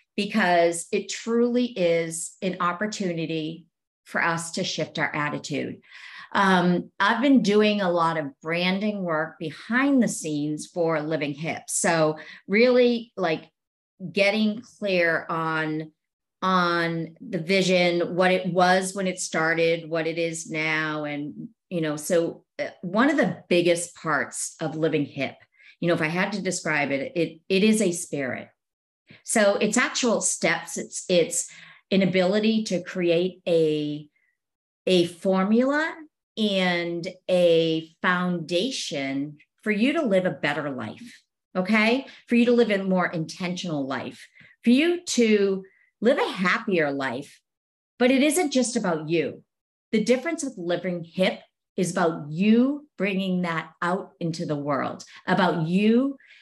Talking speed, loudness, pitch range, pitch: 140 wpm, -24 LUFS, 160-205 Hz, 180 Hz